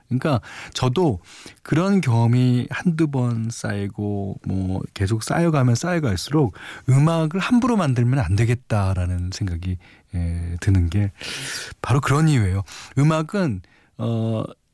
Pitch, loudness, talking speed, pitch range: 115 Hz, -22 LUFS, 255 characters per minute, 100-145 Hz